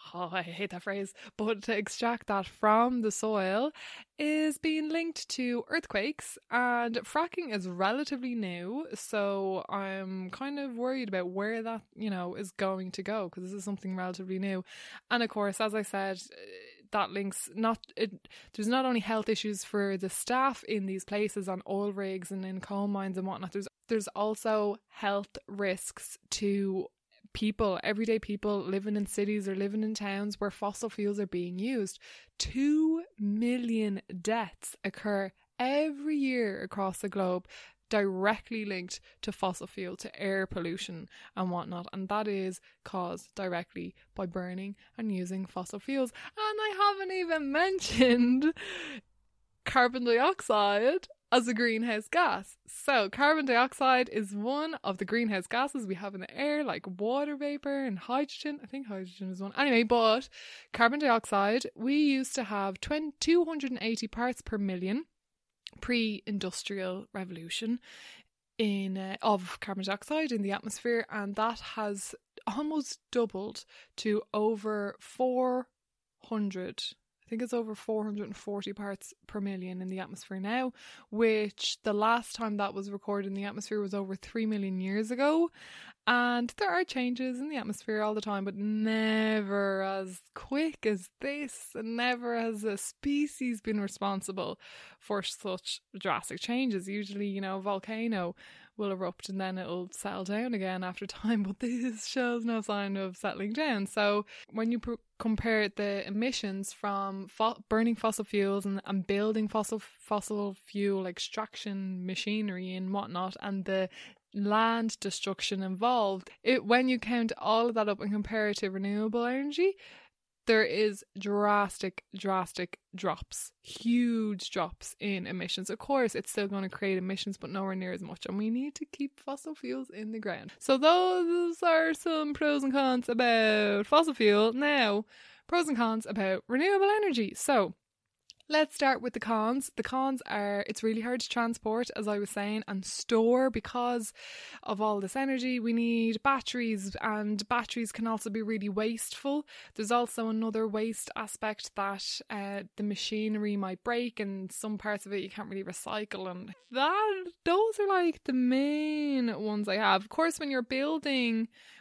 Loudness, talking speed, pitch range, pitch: -32 LUFS, 160 wpm, 195-245 Hz, 215 Hz